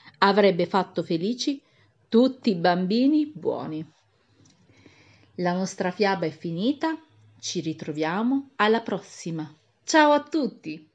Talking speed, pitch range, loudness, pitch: 105 wpm, 165-245 Hz, -24 LUFS, 190 Hz